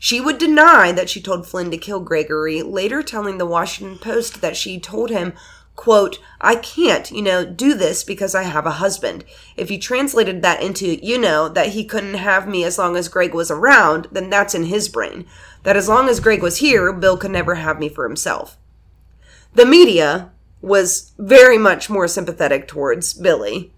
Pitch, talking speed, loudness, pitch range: 195 Hz, 195 wpm, -15 LUFS, 175-225 Hz